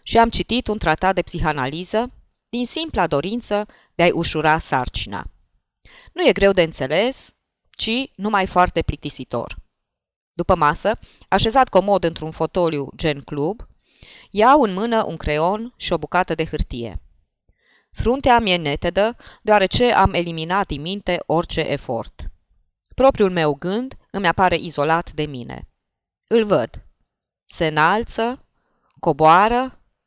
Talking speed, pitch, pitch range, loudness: 130 wpm, 175 Hz, 155-215 Hz, -19 LUFS